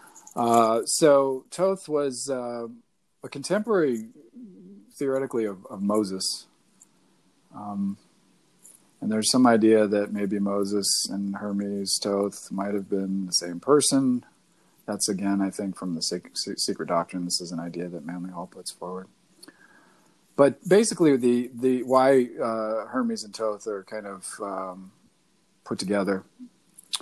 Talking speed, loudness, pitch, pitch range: 140 wpm, -25 LUFS, 110 Hz, 100-135 Hz